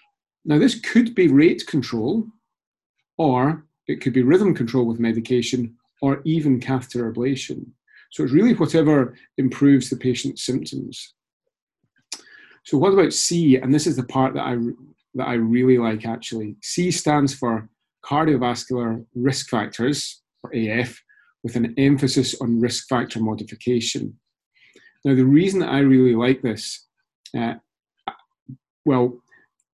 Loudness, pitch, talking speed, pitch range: -20 LUFS, 130 Hz, 135 wpm, 120-145 Hz